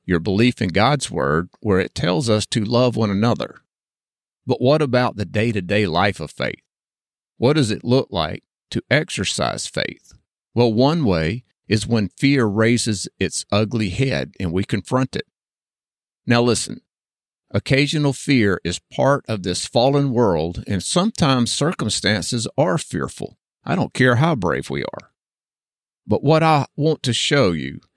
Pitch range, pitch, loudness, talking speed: 100-135 Hz, 120 Hz, -19 LUFS, 155 wpm